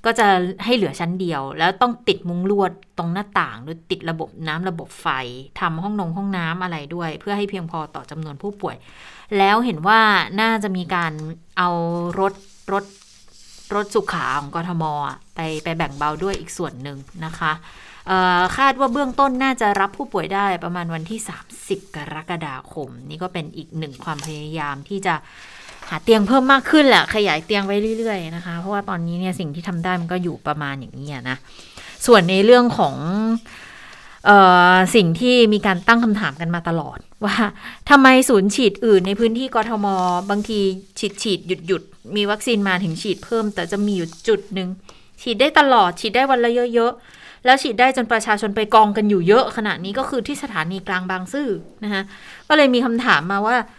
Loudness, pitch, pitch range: -18 LUFS, 195 Hz, 170-220 Hz